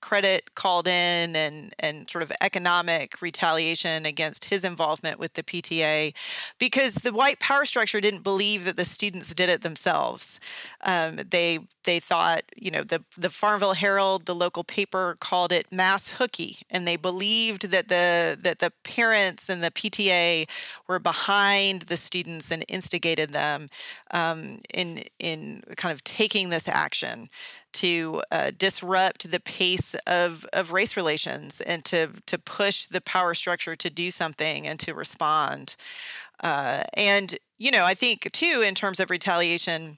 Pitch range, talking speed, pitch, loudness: 170-200 Hz, 155 wpm, 180 Hz, -24 LUFS